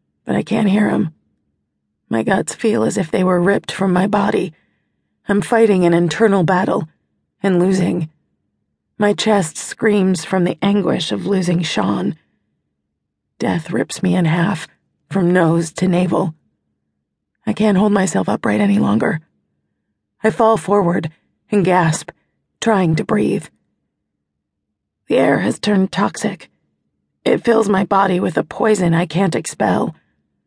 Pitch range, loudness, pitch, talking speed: 160-200 Hz, -17 LUFS, 185 Hz, 140 wpm